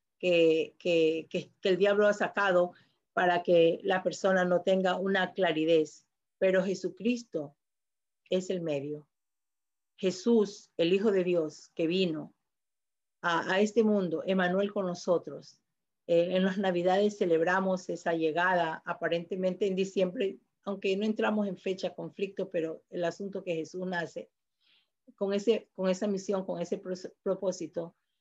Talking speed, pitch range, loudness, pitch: 140 wpm, 170-195 Hz, -30 LUFS, 185 Hz